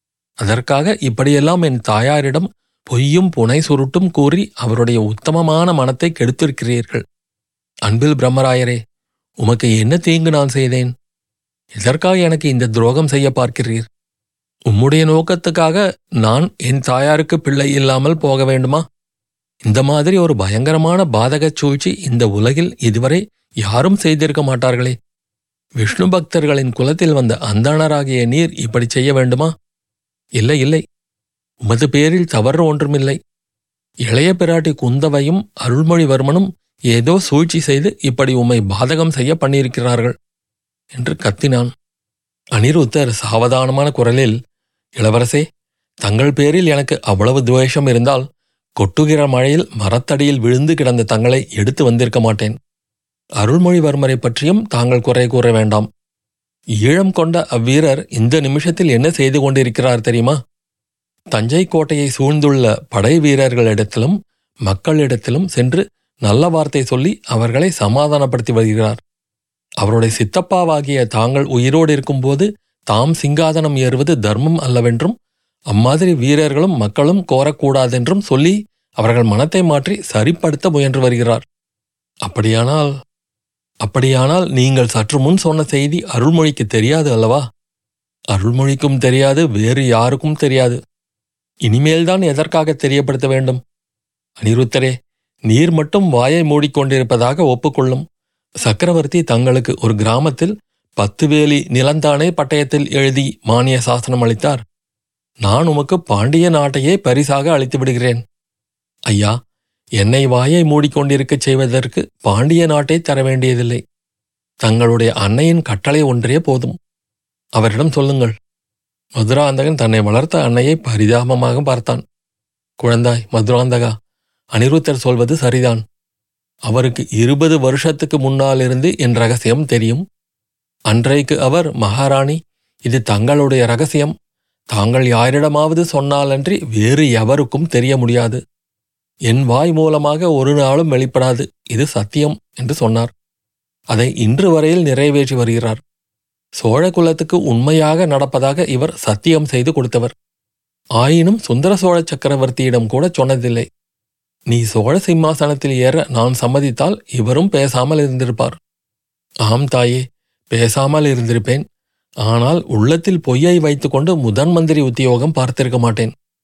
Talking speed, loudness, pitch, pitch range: 105 wpm, -14 LUFS, 135 Hz, 120-155 Hz